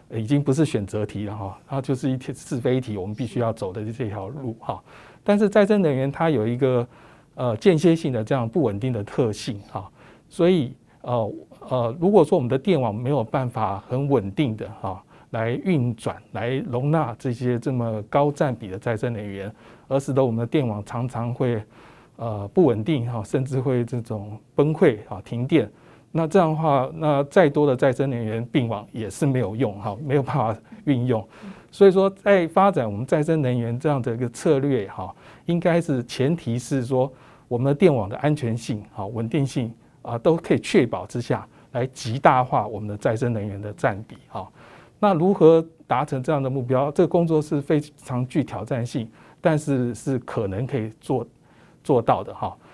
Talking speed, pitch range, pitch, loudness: 275 characters per minute, 115-150 Hz, 130 Hz, -23 LUFS